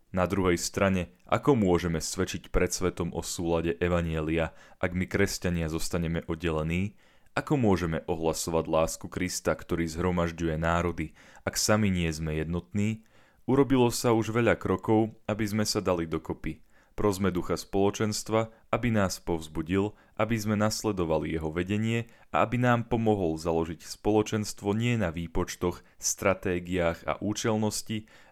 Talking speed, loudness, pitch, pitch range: 130 wpm, -29 LUFS, 90 Hz, 85-105 Hz